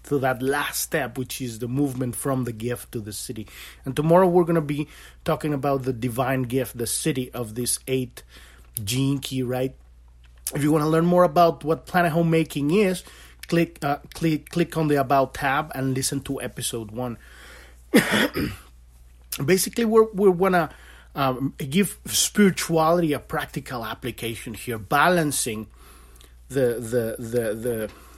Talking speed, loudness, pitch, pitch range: 160 wpm, -23 LUFS, 130 Hz, 115-160 Hz